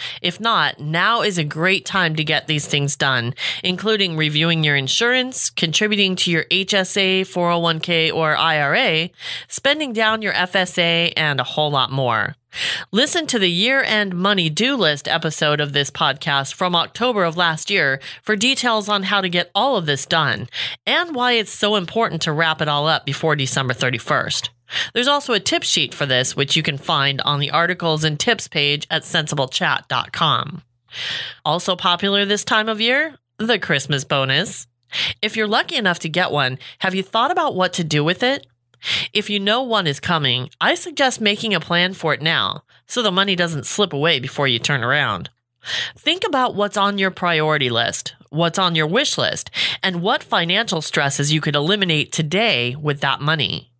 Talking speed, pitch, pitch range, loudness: 180 wpm, 170 Hz, 145-205 Hz, -18 LUFS